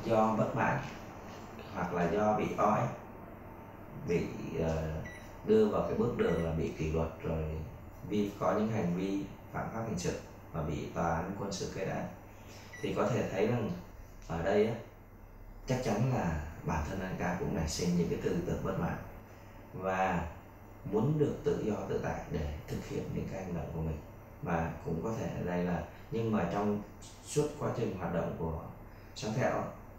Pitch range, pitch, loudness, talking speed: 85-110 Hz, 100 Hz, -34 LUFS, 185 wpm